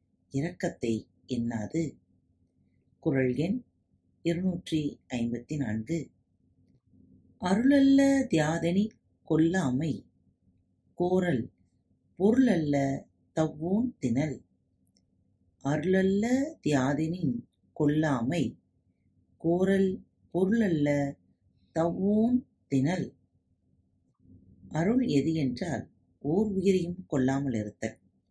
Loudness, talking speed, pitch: -29 LUFS, 60 wpm, 140 Hz